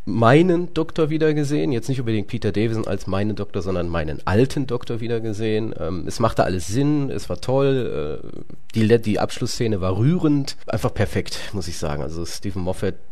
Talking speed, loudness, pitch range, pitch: 175 wpm, -22 LUFS, 95-135 Hz, 110 Hz